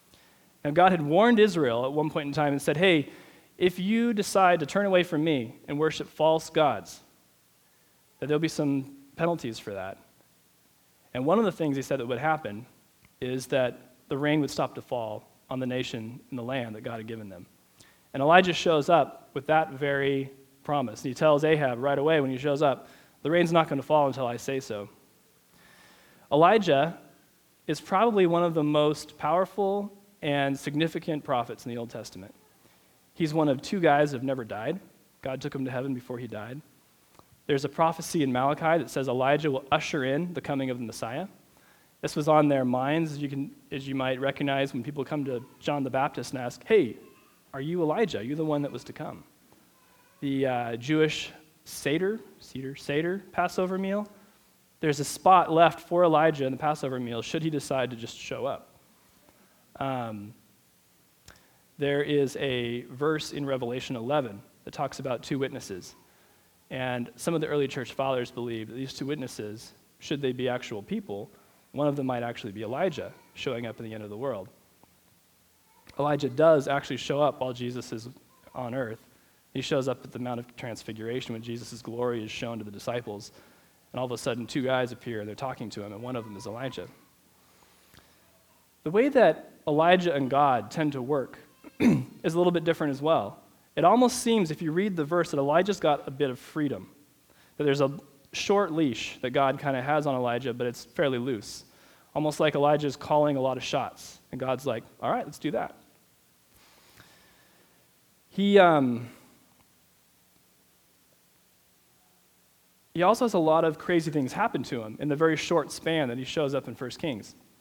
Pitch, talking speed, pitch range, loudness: 140 Hz, 190 wpm, 125-160 Hz, -27 LUFS